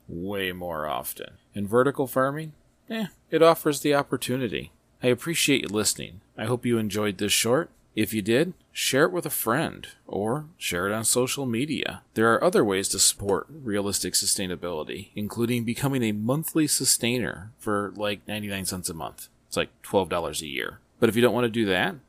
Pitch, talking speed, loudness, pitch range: 115 Hz, 180 wpm, -25 LUFS, 100-135 Hz